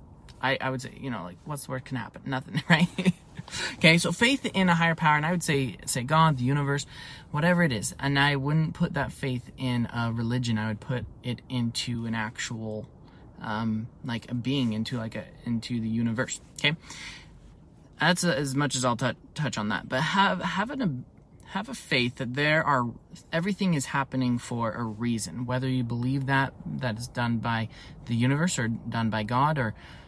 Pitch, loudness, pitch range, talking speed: 130 Hz, -27 LUFS, 120-150 Hz, 200 wpm